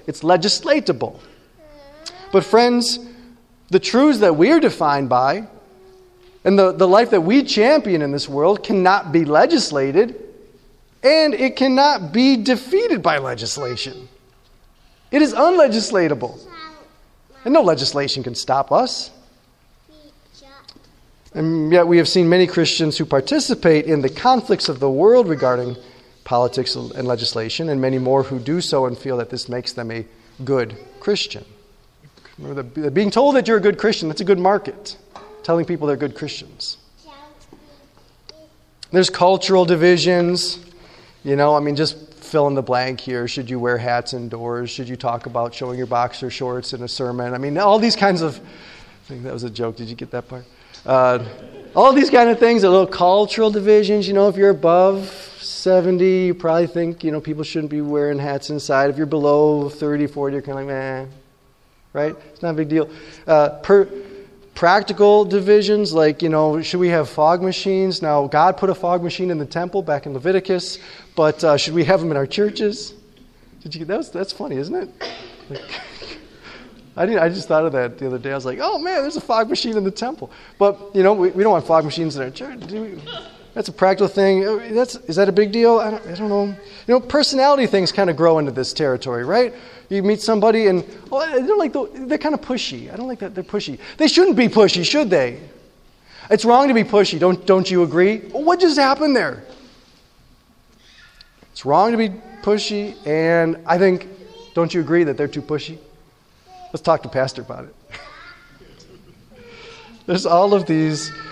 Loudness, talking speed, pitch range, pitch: -17 LUFS, 185 wpm, 145-210 Hz, 180 Hz